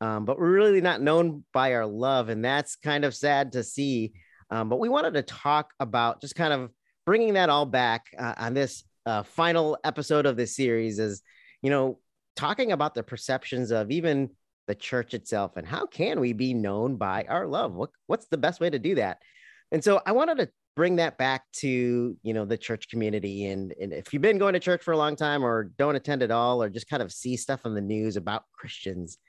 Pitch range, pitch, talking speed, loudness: 115-145 Hz, 130 Hz, 225 wpm, -27 LUFS